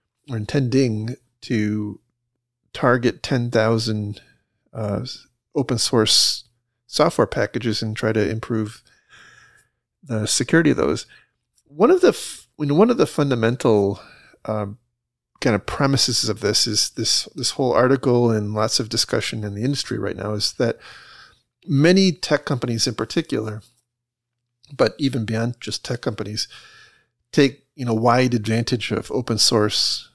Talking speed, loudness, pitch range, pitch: 135 wpm, -20 LUFS, 110-135 Hz, 120 Hz